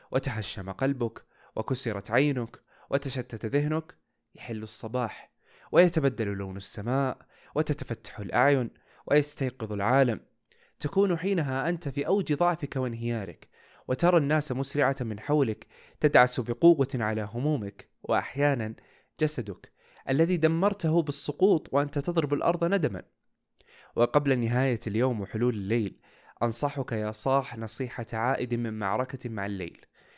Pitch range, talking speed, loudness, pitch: 115-145 Hz, 105 wpm, -28 LUFS, 130 Hz